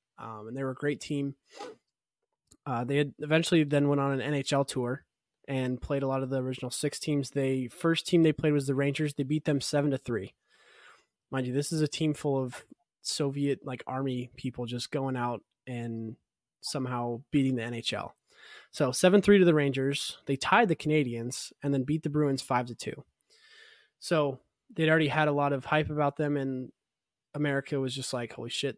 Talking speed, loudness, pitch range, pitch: 195 wpm, -29 LUFS, 130-150 Hz, 140 Hz